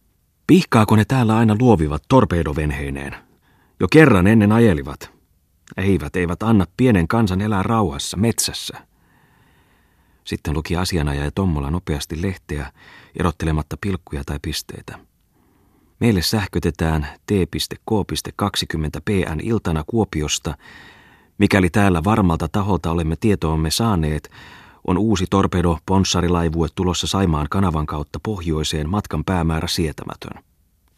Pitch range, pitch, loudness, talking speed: 80-100 Hz, 90 Hz, -19 LUFS, 100 wpm